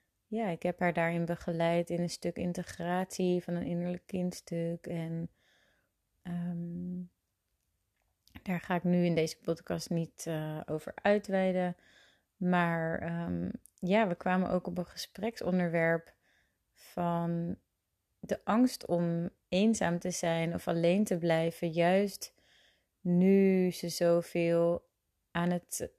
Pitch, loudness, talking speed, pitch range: 175 Hz, -32 LUFS, 120 wpm, 170-180 Hz